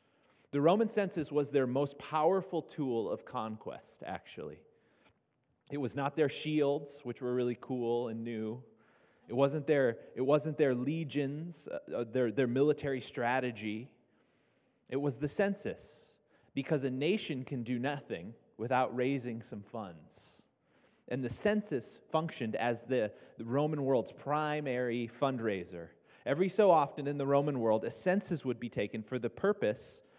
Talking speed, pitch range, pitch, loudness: 145 wpm, 120-150 Hz, 140 Hz, -34 LUFS